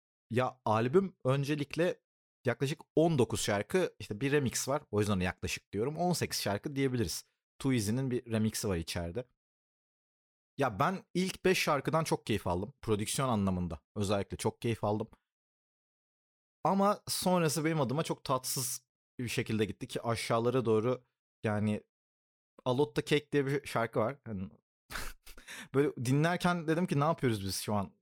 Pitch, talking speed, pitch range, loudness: 125 Hz, 140 wpm, 105-150 Hz, -33 LUFS